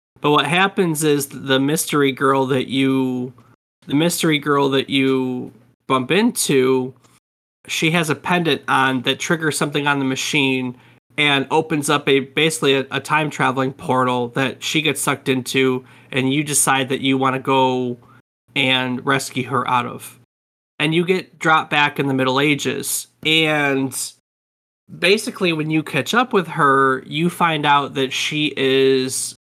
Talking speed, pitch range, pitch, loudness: 160 wpm, 130-155 Hz, 135 Hz, -18 LUFS